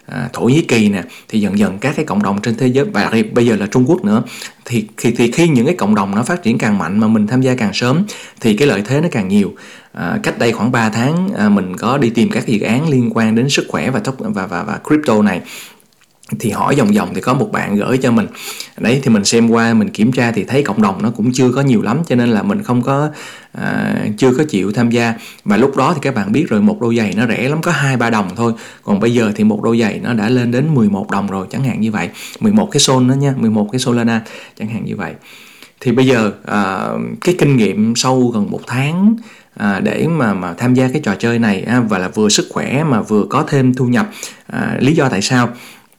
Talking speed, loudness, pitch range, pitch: 265 wpm, -14 LUFS, 115-185 Hz, 130 Hz